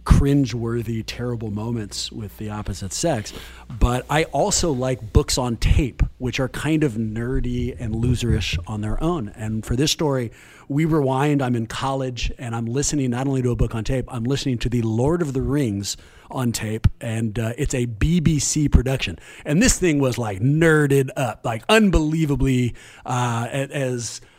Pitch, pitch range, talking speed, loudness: 125 Hz, 115-140 Hz, 175 wpm, -22 LUFS